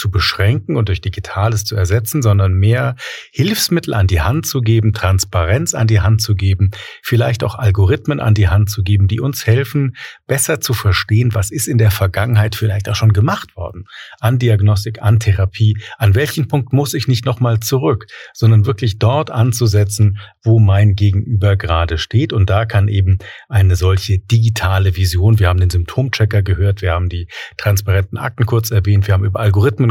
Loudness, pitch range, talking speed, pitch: -15 LUFS, 100-120 Hz, 180 wpm, 105 Hz